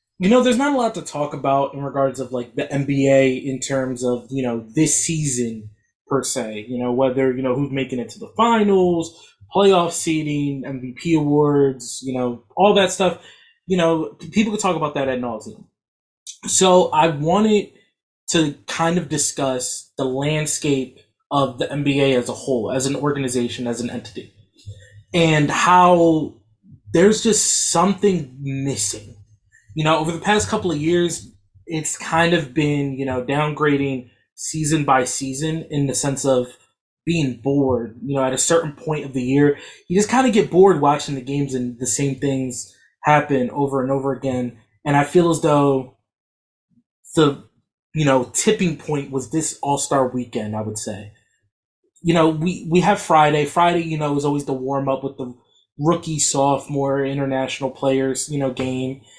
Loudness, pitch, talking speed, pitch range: -19 LUFS, 140 Hz, 170 wpm, 130-160 Hz